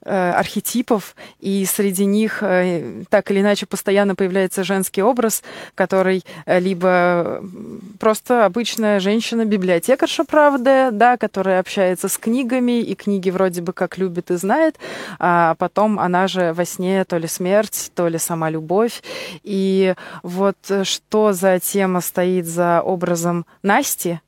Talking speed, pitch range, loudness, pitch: 130 wpm, 180-210 Hz, -18 LUFS, 195 Hz